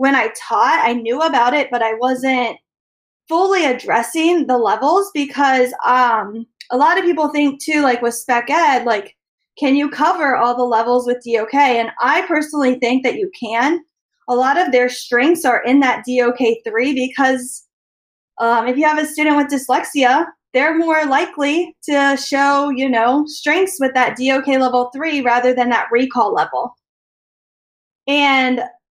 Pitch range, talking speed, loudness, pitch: 245-295 Hz, 165 wpm, -16 LUFS, 265 Hz